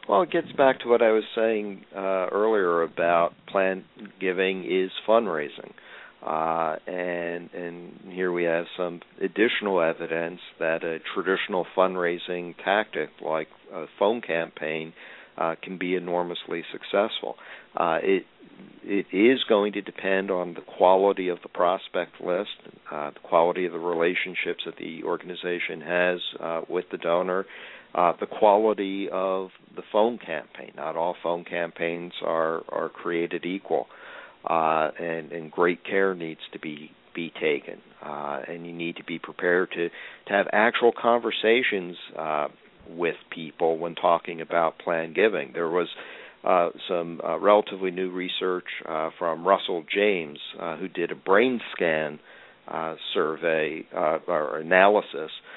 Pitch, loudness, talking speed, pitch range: 90 Hz, -26 LUFS, 145 wpm, 85-95 Hz